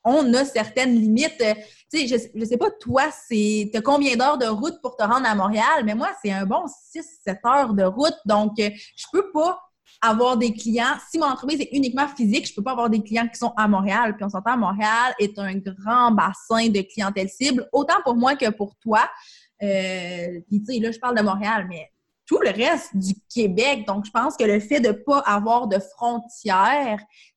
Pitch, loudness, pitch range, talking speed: 225 Hz, -21 LUFS, 205-260 Hz, 220 wpm